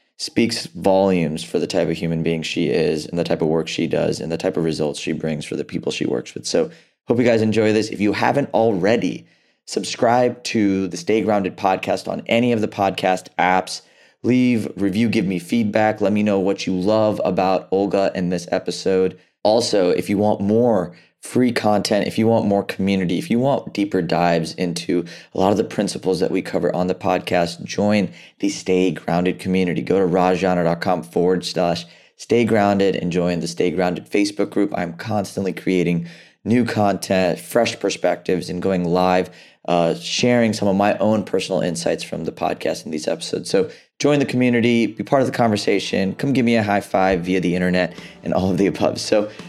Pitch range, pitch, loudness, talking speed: 90-110 Hz, 95 Hz, -20 LUFS, 200 wpm